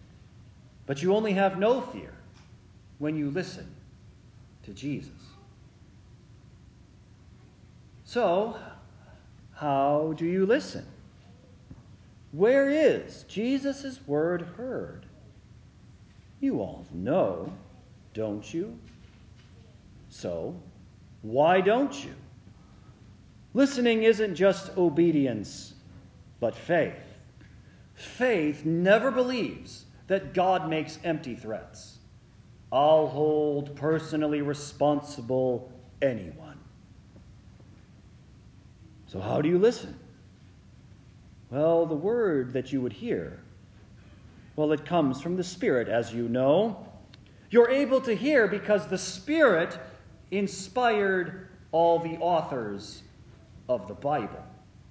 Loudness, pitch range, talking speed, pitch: -27 LUFS, 105-175 Hz, 90 wpm, 130 Hz